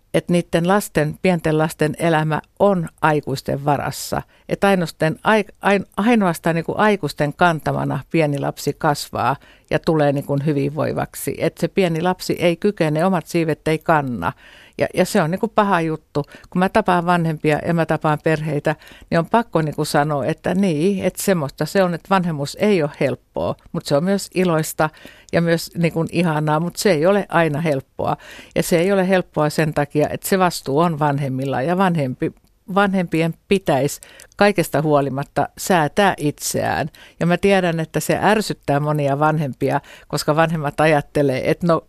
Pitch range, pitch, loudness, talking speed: 150-185 Hz, 160 Hz, -19 LUFS, 160 wpm